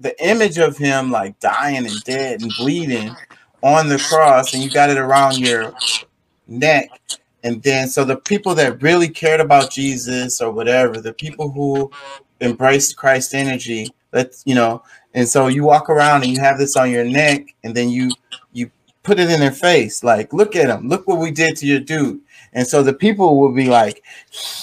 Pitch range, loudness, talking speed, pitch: 125-150 Hz, -15 LUFS, 195 wpm, 135 Hz